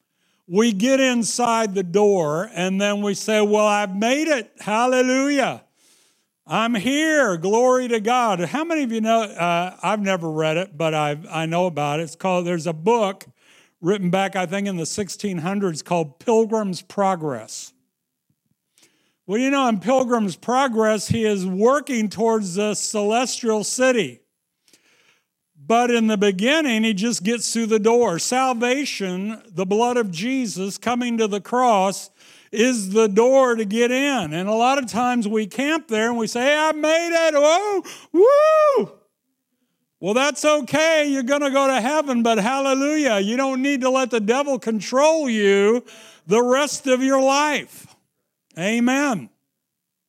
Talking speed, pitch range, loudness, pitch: 155 wpm, 195-260 Hz, -20 LUFS, 225 Hz